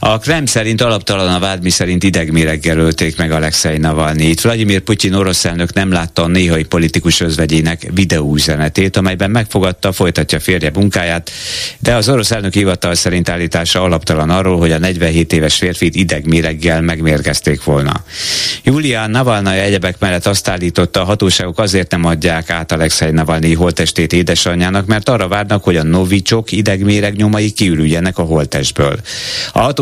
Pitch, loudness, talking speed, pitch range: 90 Hz, -12 LUFS, 150 wpm, 80-100 Hz